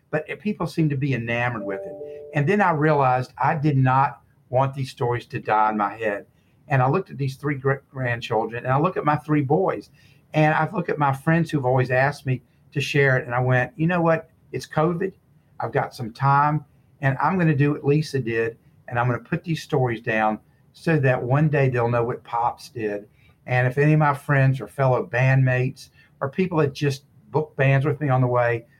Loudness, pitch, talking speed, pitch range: -22 LUFS, 140 Hz, 225 wpm, 125-150 Hz